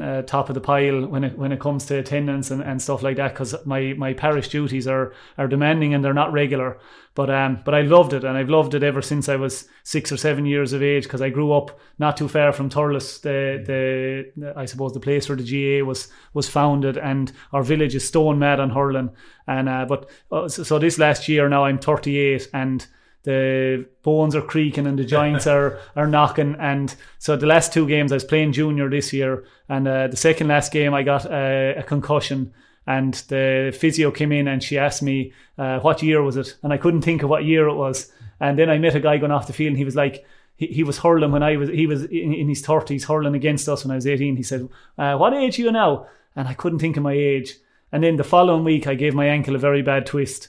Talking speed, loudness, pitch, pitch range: 245 wpm, -20 LUFS, 140 Hz, 135-150 Hz